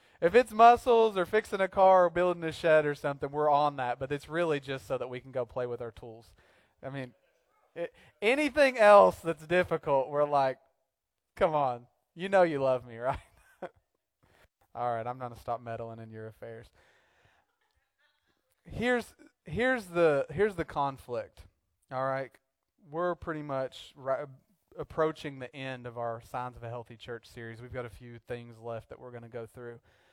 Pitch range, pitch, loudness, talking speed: 120-170 Hz, 135 Hz, -28 LUFS, 175 wpm